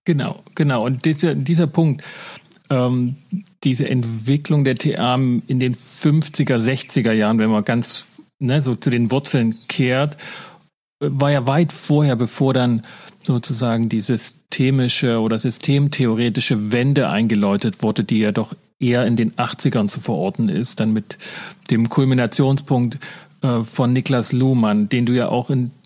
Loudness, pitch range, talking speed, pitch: -19 LUFS, 120-145 Hz, 145 wpm, 130 Hz